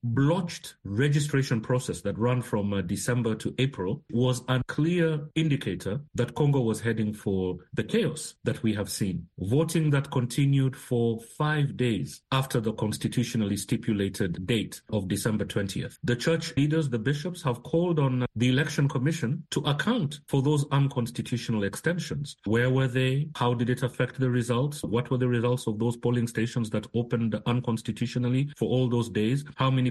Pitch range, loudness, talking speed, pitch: 115-140 Hz, -28 LUFS, 165 wpm, 125 Hz